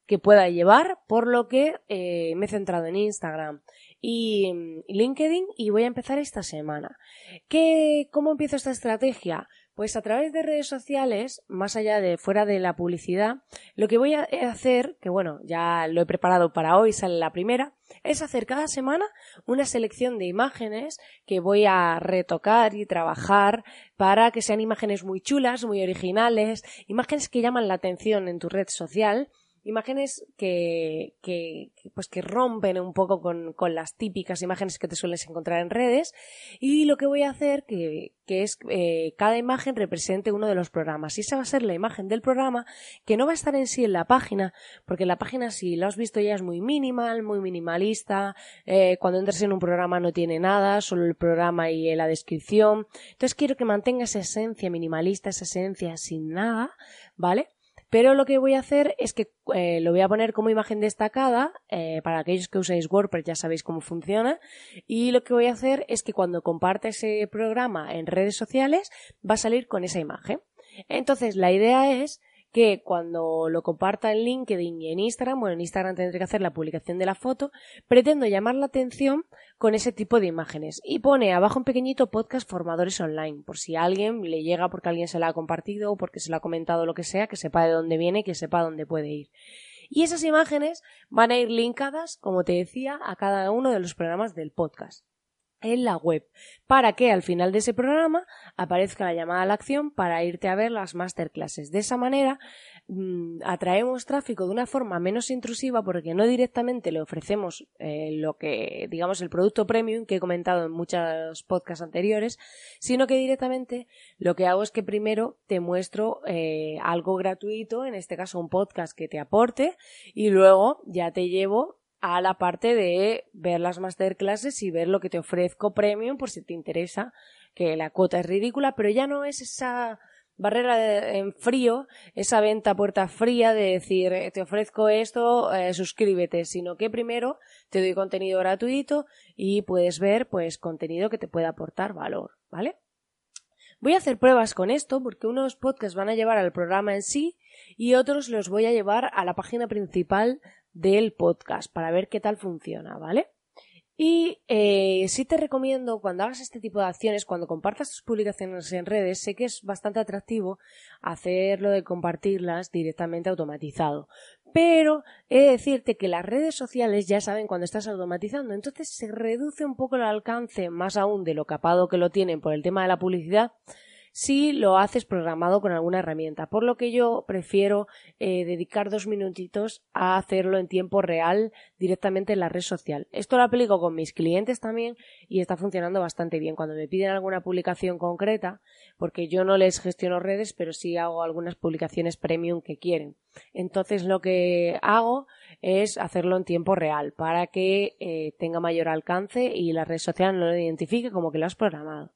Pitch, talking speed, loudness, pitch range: 200 Hz, 190 wpm, -25 LUFS, 175-235 Hz